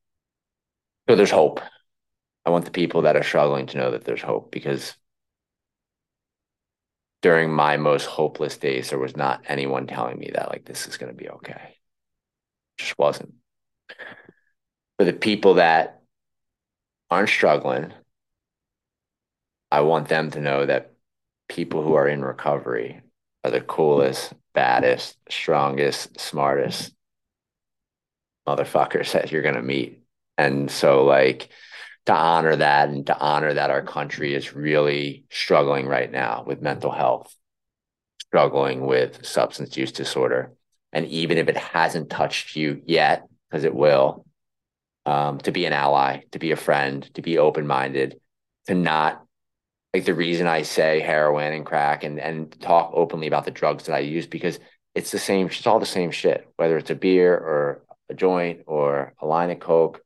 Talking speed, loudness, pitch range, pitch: 155 wpm, -22 LUFS, 70-85 Hz, 75 Hz